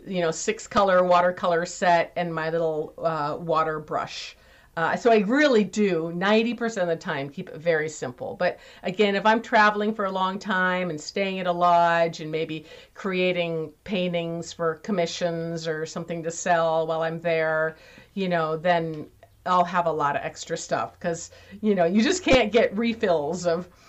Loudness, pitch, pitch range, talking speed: -24 LUFS, 175 Hz, 165-195 Hz, 180 wpm